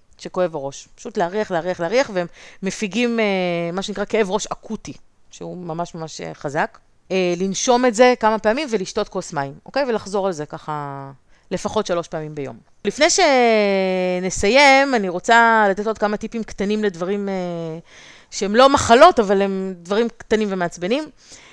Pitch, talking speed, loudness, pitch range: 195 Hz, 155 wpm, -19 LUFS, 175-220 Hz